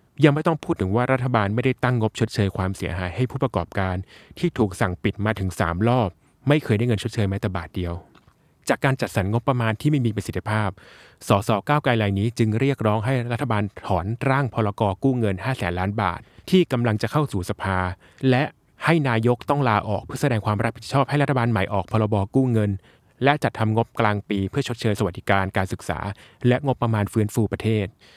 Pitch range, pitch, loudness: 100-130 Hz, 110 Hz, -23 LUFS